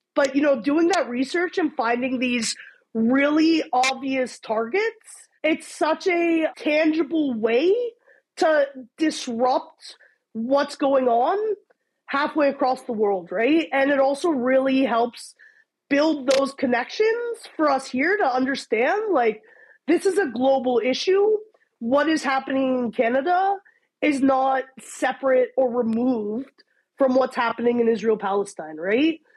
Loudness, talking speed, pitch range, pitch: -22 LUFS, 130 wpm, 250-325 Hz, 275 Hz